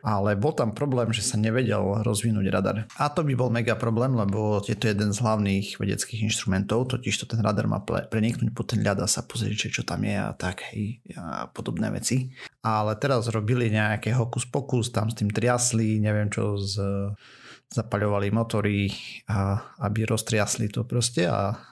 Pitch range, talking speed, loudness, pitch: 105-120 Hz, 175 wpm, -26 LUFS, 110 Hz